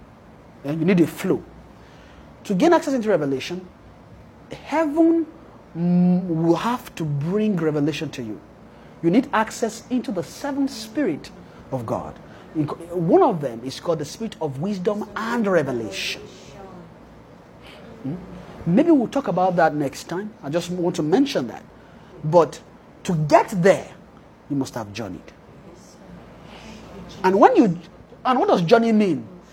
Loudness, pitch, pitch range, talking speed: -21 LUFS, 180 Hz, 155-230 Hz, 135 wpm